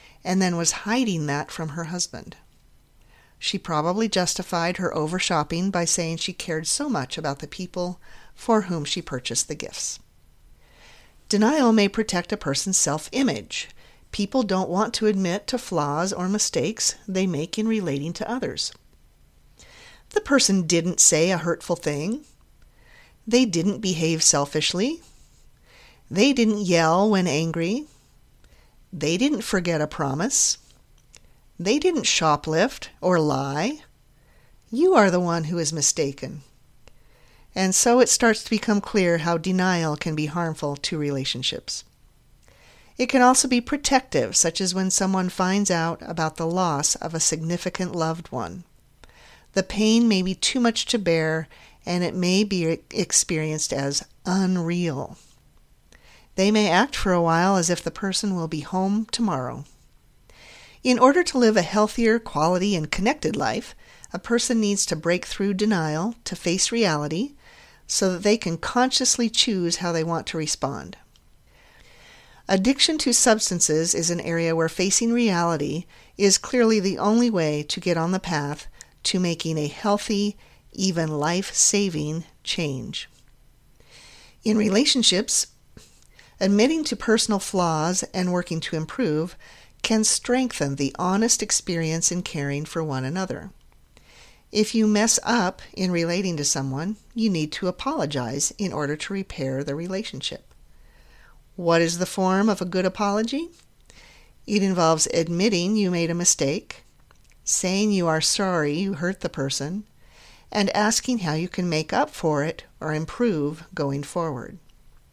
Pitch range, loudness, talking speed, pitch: 160-210 Hz, -22 LUFS, 145 wpm, 180 Hz